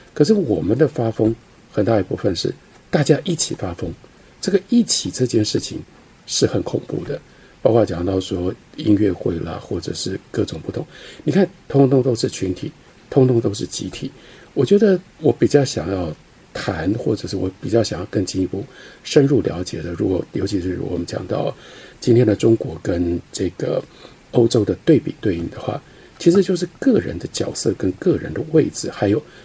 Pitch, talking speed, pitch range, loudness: 115 Hz, 265 characters per minute, 95-155 Hz, -20 LUFS